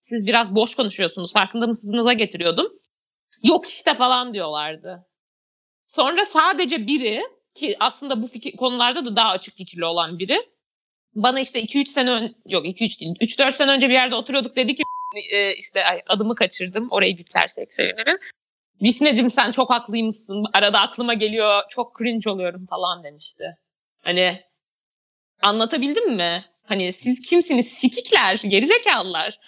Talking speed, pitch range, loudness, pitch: 140 wpm, 195-265 Hz, -19 LUFS, 230 Hz